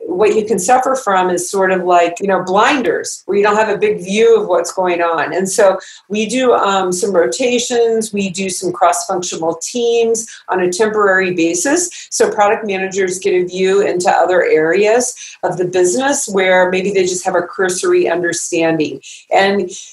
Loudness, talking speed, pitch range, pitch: -14 LUFS, 180 wpm, 180-220 Hz, 190 Hz